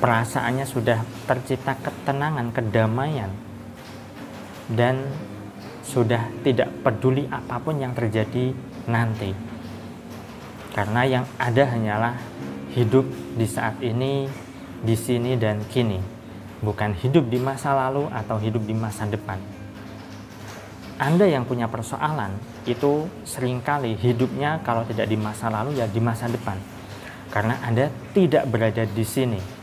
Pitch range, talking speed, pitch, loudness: 110-130 Hz, 115 wpm, 120 Hz, -24 LUFS